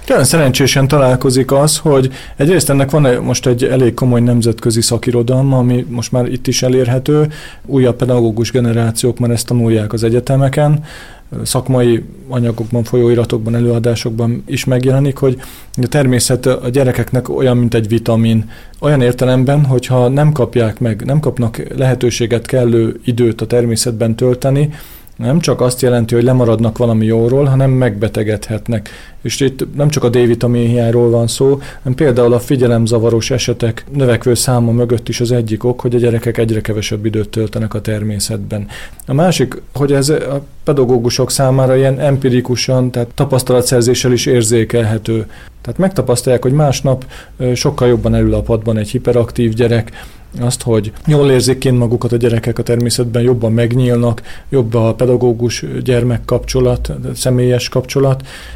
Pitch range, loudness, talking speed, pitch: 115-130 Hz, -13 LUFS, 145 wpm, 125 Hz